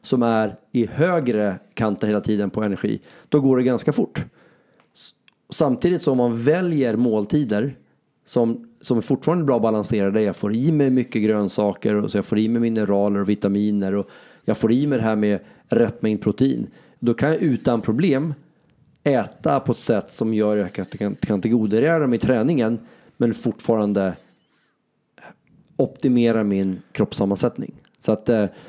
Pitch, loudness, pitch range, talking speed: 110 Hz, -21 LUFS, 105-135 Hz, 165 wpm